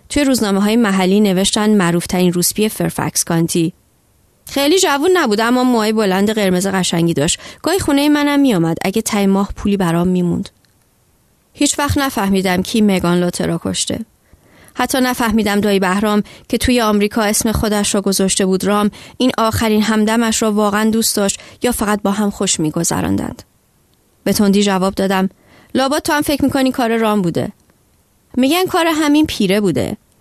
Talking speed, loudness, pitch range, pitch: 155 wpm, -15 LUFS, 190-245 Hz, 210 Hz